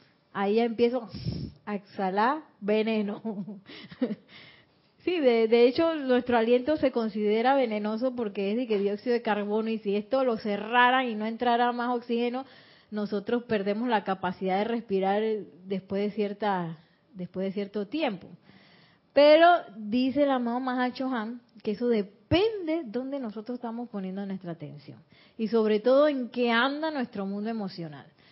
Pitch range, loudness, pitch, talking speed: 205-245 Hz, -27 LUFS, 225 Hz, 145 wpm